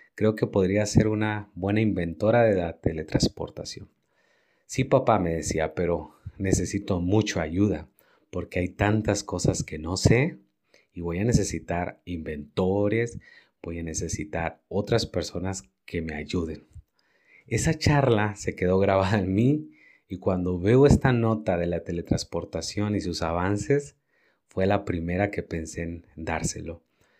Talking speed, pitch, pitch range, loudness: 140 wpm, 95 Hz, 85-110 Hz, -26 LUFS